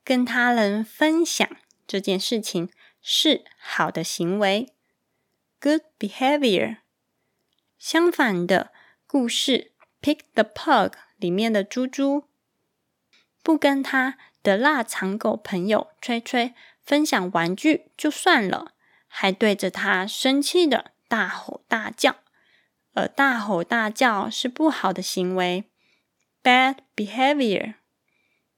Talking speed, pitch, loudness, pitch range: 205 characters per minute, 240 Hz, -22 LUFS, 195-285 Hz